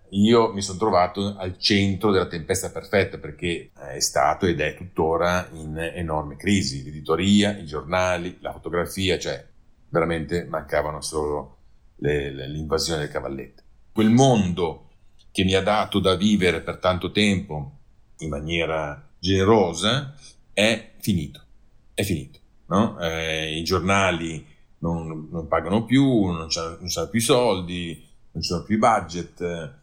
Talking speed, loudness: 135 wpm, -23 LUFS